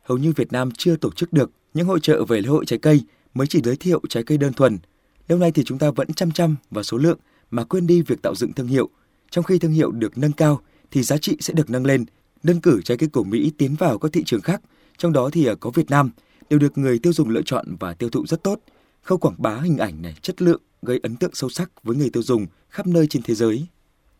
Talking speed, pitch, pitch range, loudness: 270 wpm, 150 Hz, 120-170 Hz, -21 LUFS